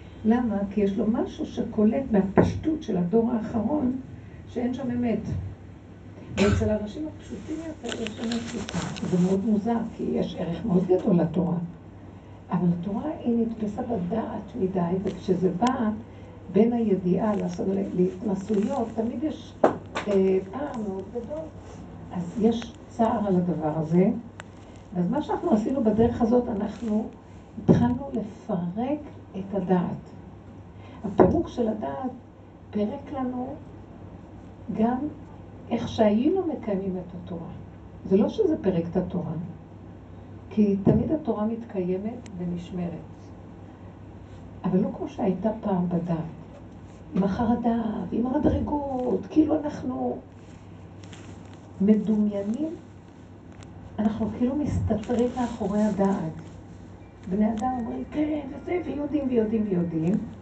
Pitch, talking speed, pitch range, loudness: 205 Hz, 110 wpm, 170-235 Hz, -26 LUFS